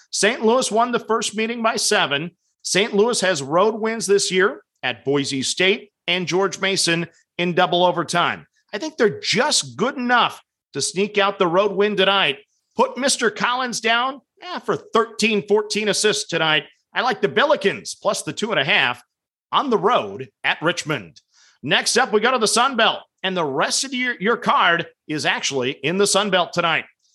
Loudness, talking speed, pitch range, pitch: -19 LUFS, 185 wpm, 175-225 Hz, 200 Hz